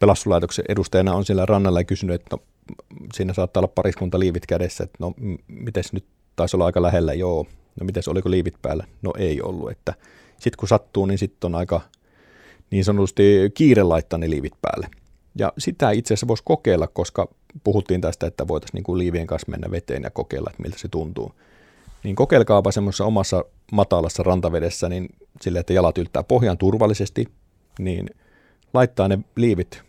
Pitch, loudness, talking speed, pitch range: 95 Hz, -21 LUFS, 170 wpm, 85-100 Hz